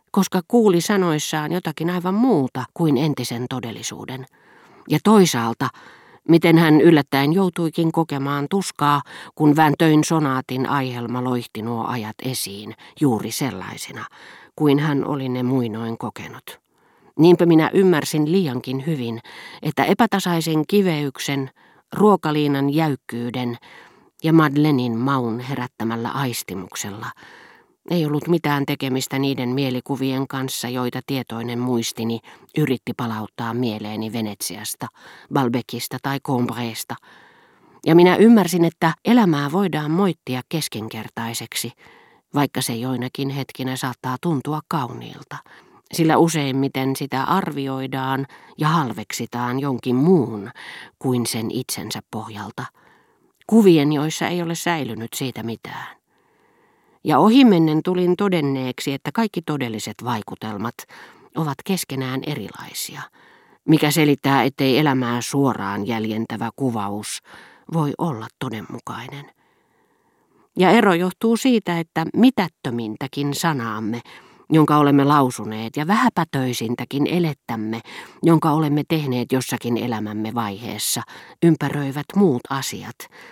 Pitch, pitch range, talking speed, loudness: 140 Hz, 125-165 Hz, 100 wpm, -20 LUFS